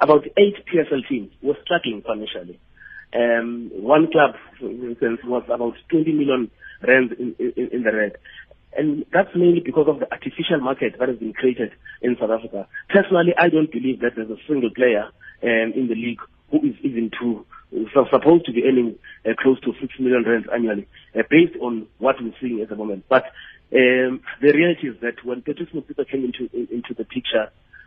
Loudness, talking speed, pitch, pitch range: -20 LUFS, 195 wpm, 130 Hz, 115-155 Hz